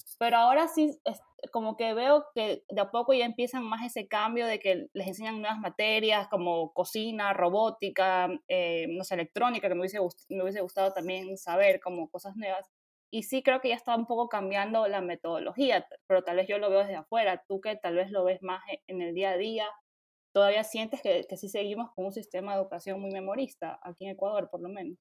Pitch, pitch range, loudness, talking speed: 200 Hz, 185-225 Hz, -30 LUFS, 215 wpm